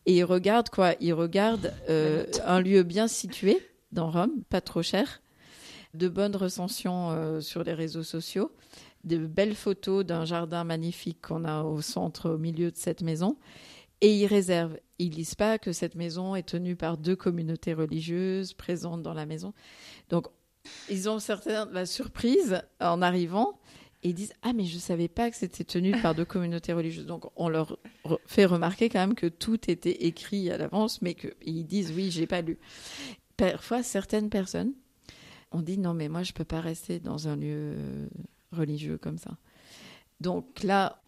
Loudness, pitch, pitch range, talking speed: -29 LUFS, 175 Hz, 165-200 Hz, 180 wpm